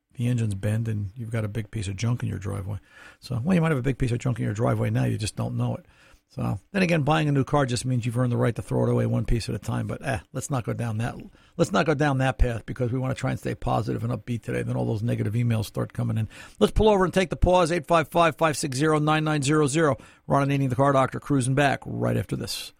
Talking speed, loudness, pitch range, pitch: 280 wpm, -25 LUFS, 115-150 Hz, 125 Hz